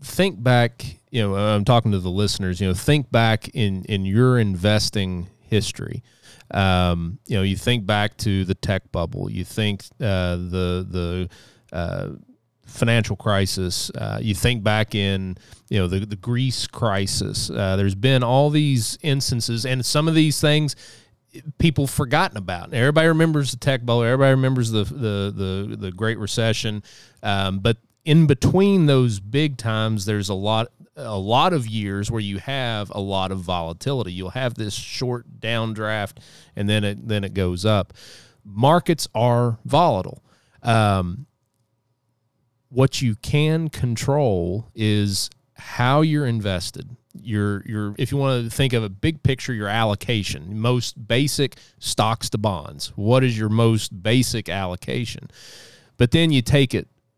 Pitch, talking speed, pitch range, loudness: 115 Hz, 155 wpm, 100-130 Hz, -21 LUFS